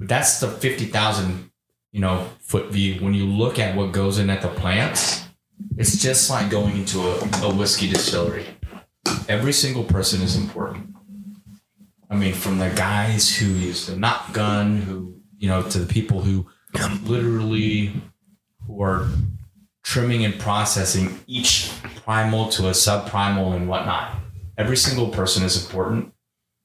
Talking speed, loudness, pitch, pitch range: 145 wpm, -21 LUFS, 100 Hz, 95-110 Hz